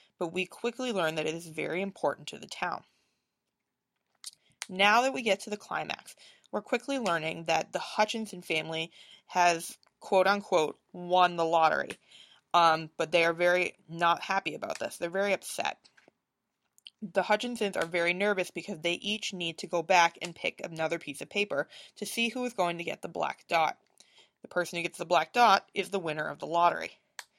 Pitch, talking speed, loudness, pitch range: 180 Hz, 185 wpm, -30 LUFS, 170-210 Hz